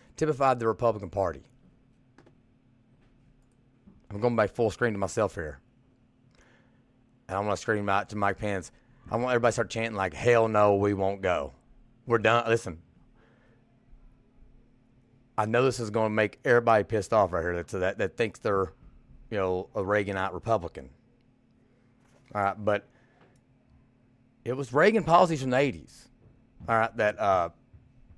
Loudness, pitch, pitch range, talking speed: -27 LUFS, 120 Hz, 105-125 Hz, 150 wpm